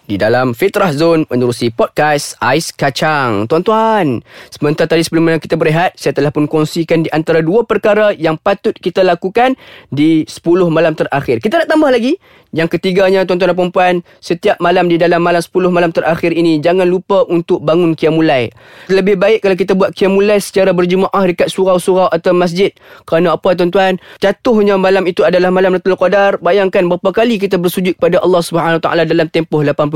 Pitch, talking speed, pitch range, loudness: 180 Hz, 170 wpm, 160-195 Hz, -12 LUFS